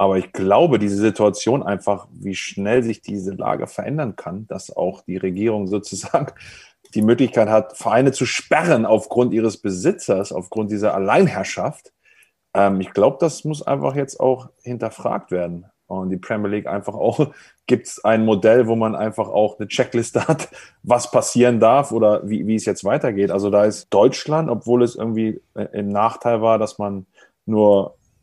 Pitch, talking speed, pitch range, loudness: 110 Hz, 165 wpm, 100-120 Hz, -19 LUFS